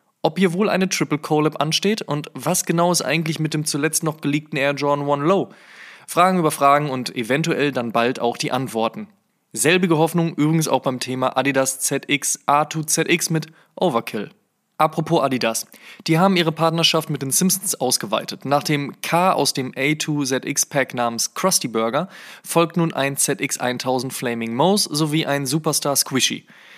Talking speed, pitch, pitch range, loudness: 160 wpm, 155 Hz, 135-170 Hz, -20 LUFS